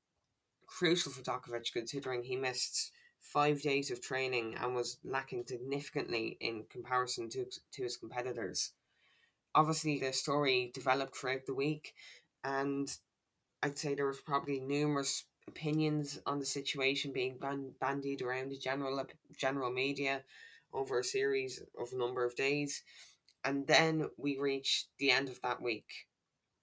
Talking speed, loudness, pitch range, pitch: 140 wpm, -36 LUFS, 130-150 Hz, 135 Hz